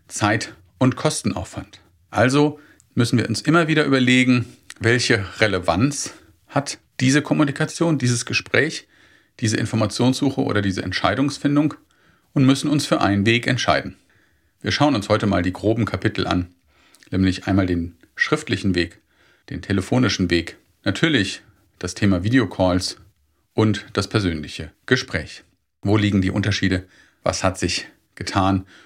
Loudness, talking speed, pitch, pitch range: -20 LUFS, 130 wpm, 105 Hz, 95-130 Hz